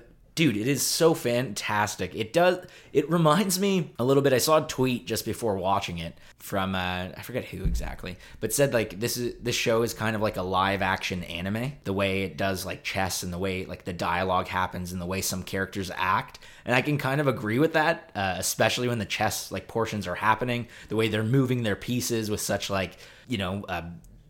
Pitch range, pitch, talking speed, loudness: 95-125 Hz, 105 Hz, 220 wpm, -27 LUFS